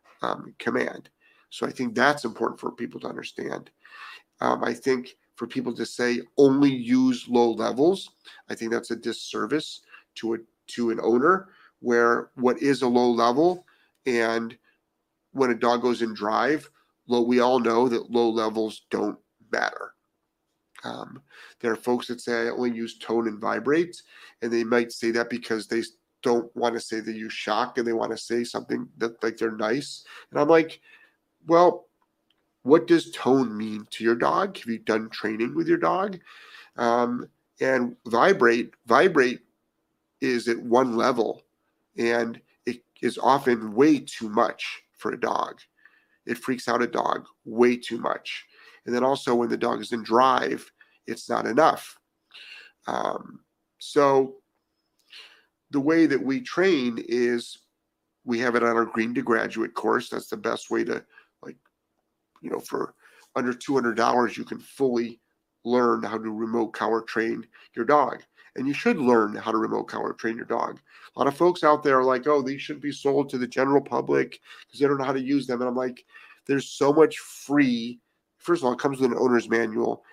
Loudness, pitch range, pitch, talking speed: -25 LUFS, 115-135 Hz, 120 Hz, 175 wpm